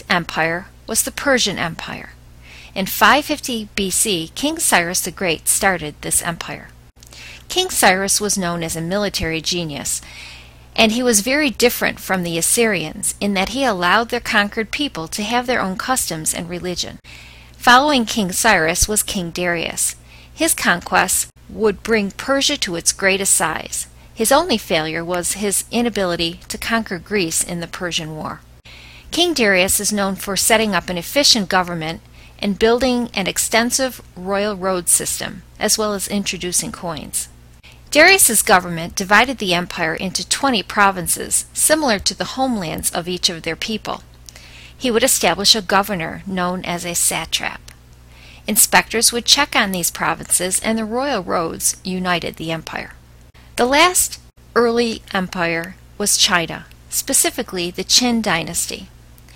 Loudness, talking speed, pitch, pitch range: -17 LUFS, 145 wpm, 190 Hz, 165-225 Hz